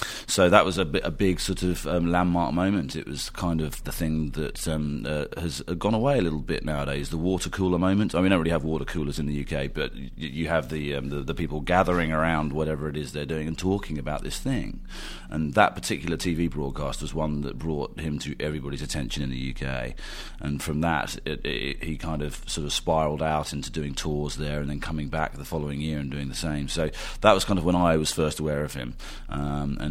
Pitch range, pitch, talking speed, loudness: 75-85 Hz, 75 Hz, 245 wpm, -27 LUFS